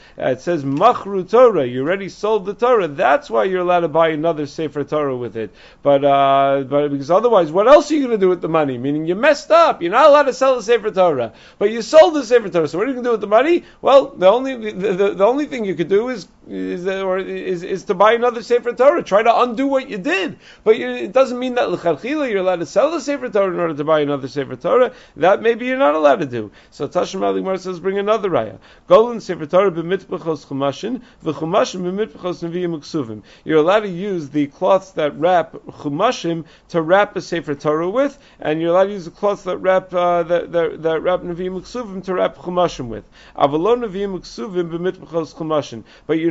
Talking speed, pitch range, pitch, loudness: 220 wpm, 155-220 Hz, 185 Hz, -17 LUFS